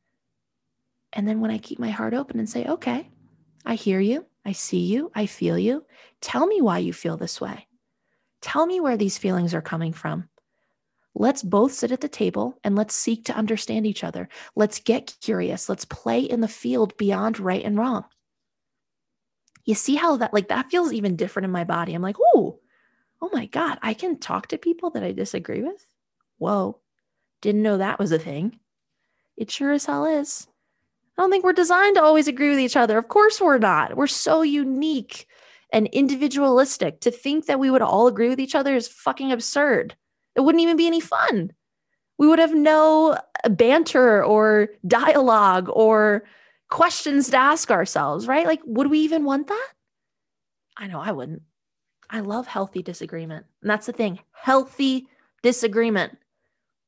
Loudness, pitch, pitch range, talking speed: -21 LUFS, 245 Hz, 210-295 Hz, 180 wpm